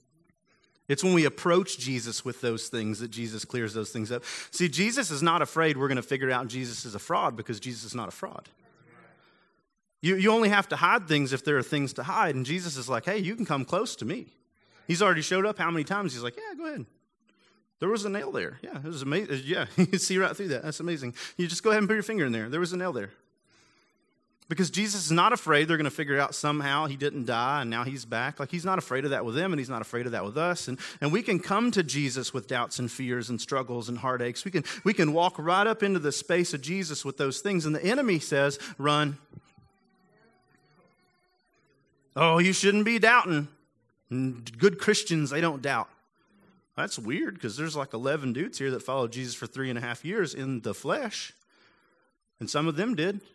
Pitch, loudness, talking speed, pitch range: 150 Hz, -28 LUFS, 235 wpm, 130-185 Hz